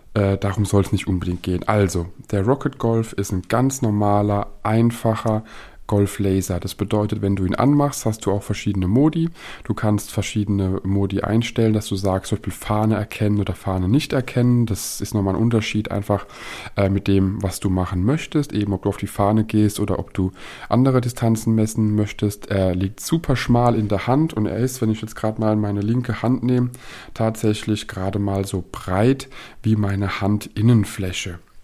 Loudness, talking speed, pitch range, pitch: -21 LUFS, 180 wpm, 100-115 Hz, 105 Hz